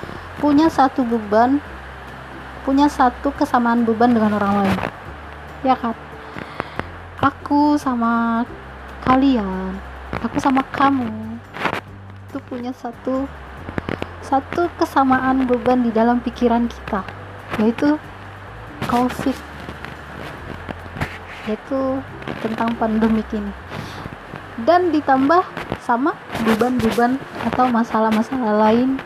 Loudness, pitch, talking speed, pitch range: -19 LUFS, 245 Hz, 85 wpm, 225-270 Hz